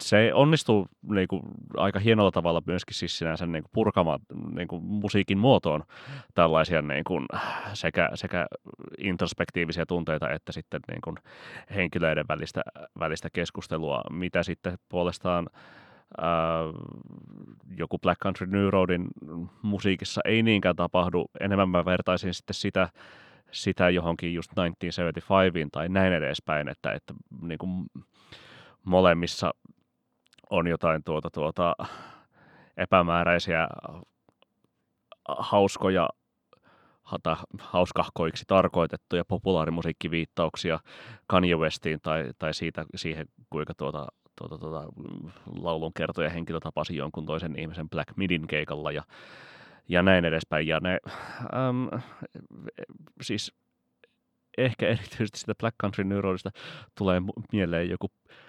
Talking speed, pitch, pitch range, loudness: 105 wpm, 90 Hz, 80-95 Hz, -28 LUFS